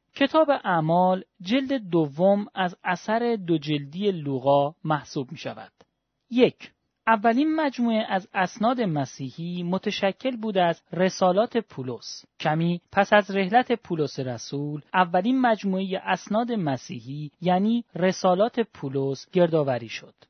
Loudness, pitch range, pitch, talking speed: -24 LUFS, 155-225 Hz, 185 Hz, 110 wpm